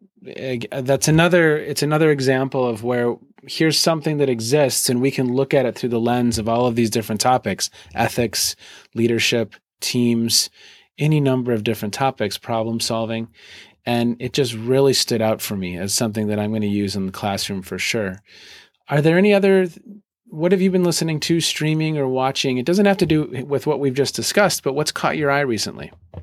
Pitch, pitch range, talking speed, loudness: 130 Hz, 115-150 Hz, 195 wpm, -19 LUFS